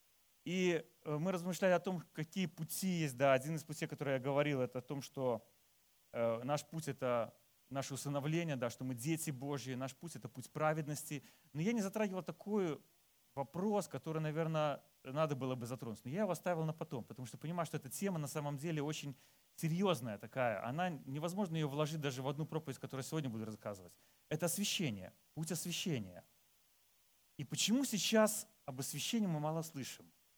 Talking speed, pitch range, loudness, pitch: 180 wpm, 135-170 Hz, -40 LUFS, 150 Hz